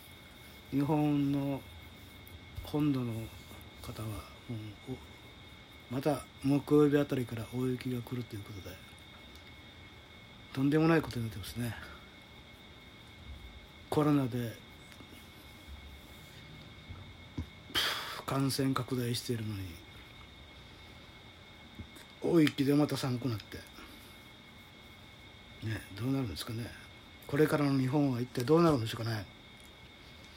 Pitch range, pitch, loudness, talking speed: 100-135 Hz, 115 Hz, -33 LUFS, 200 characters per minute